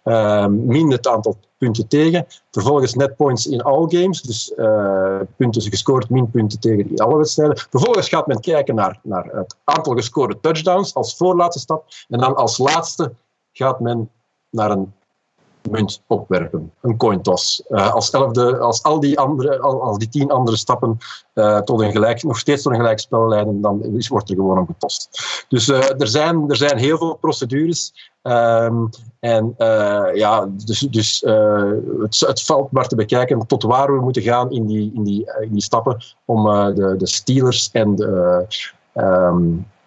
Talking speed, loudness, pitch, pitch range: 175 wpm, -17 LUFS, 120 Hz, 105-140 Hz